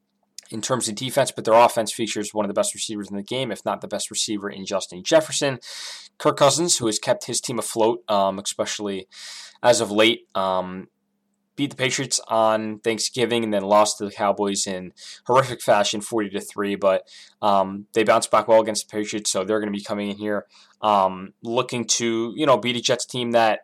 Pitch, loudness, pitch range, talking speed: 110 Hz, -22 LUFS, 100-120 Hz, 210 wpm